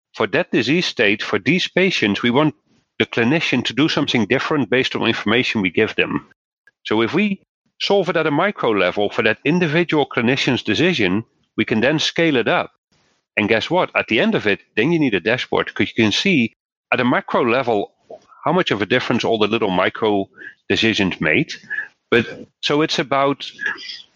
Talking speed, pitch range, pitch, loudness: 190 wpm, 110-175 Hz, 140 Hz, -18 LUFS